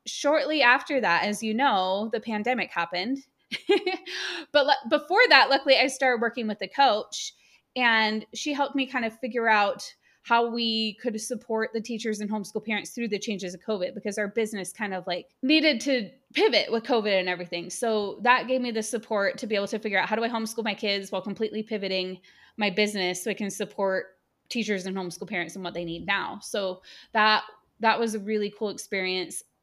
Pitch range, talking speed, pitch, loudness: 200-245 Hz, 200 wpm, 220 Hz, -26 LUFS